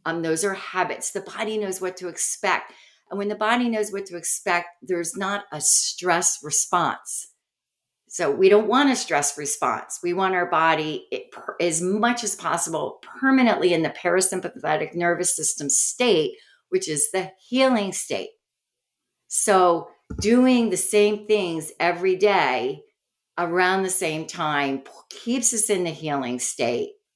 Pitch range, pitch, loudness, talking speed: 170-235 Hz, 190 Hz, -22 LUFS, 150 wpm